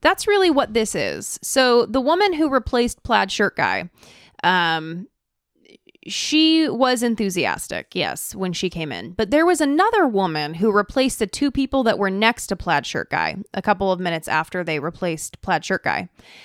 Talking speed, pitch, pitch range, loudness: 180 wpm, 225 Hz, 185-280 Hz, -20 LUFS